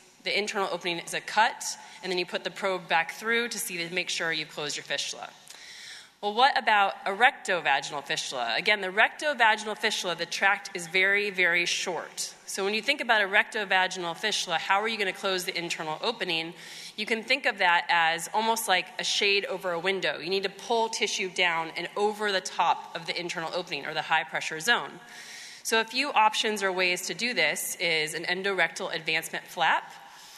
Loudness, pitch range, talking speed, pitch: -26 LUFS, 170-215 Hz, 200 wpm, 190 Hz